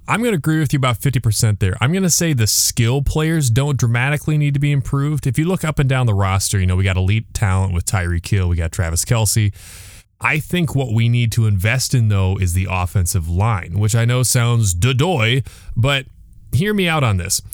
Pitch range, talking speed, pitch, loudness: 95-140 Hz, 235 wpm, 115 Hz, -17 LUFS